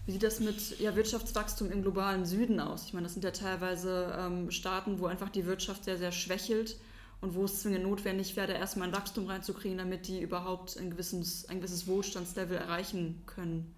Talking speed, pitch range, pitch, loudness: 195 wpm, 180-200 Hz, 190 Hz, -35 LUFS